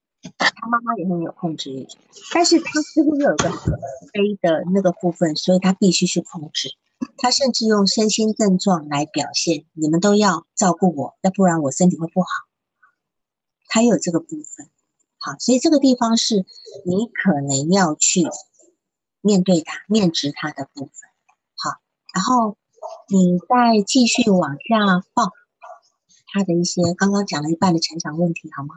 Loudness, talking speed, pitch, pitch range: -19 LUFS, 240 characters per minute, 185 Hz, 165-230 Hz